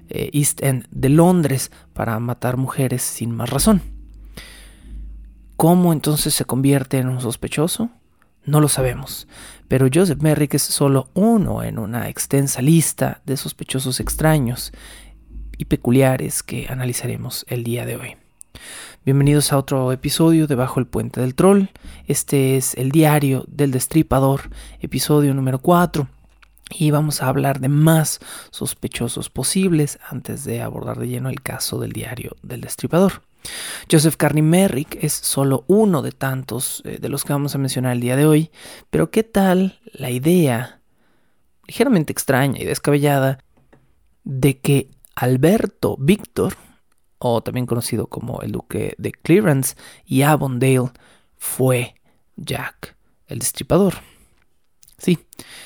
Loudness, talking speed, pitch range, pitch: -19 LUFS, 135 wpm, 125-155 Hz, 135 Hz